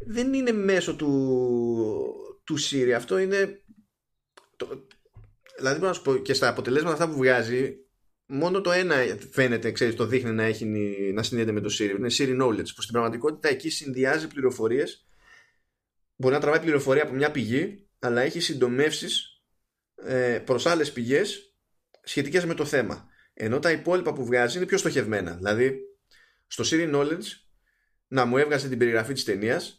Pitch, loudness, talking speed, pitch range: 140 Hz, -25 LUFS, 150 wpm, 120-185 Hz